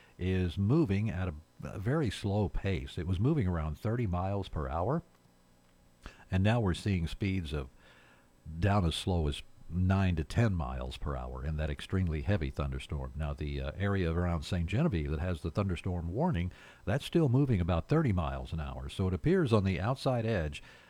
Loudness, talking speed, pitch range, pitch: -33 LUFS, 185 wpm, 75-100 Hz, 90 Hz